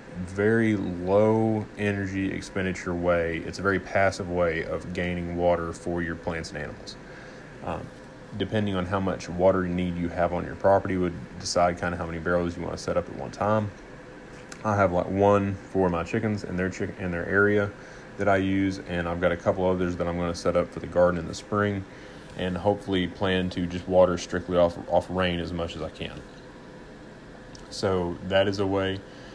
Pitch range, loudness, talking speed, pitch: 85-100 Hz, -26 LUFS, 200 wpm, 90 Hz